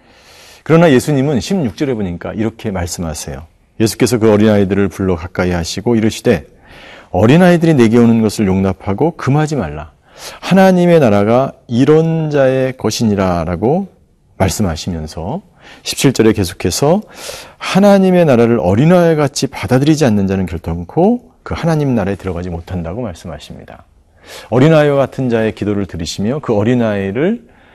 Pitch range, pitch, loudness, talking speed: 95-145 Hz, 110 Hz, -13 LUFS, 350 characters per minute